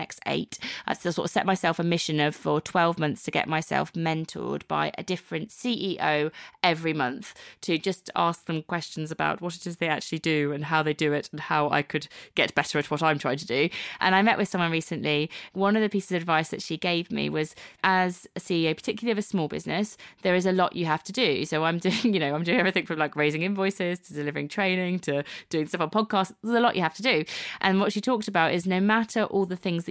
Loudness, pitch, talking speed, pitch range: -26 LUFS, 170 Hz, 250 wpm, 155-190 Hz